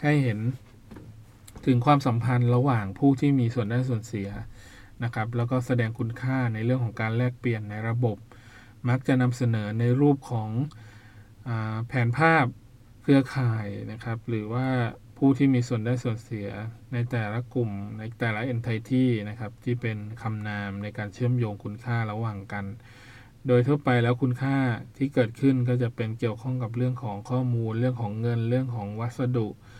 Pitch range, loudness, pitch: 110-125 Hz, -27 LUFS, 120 Hz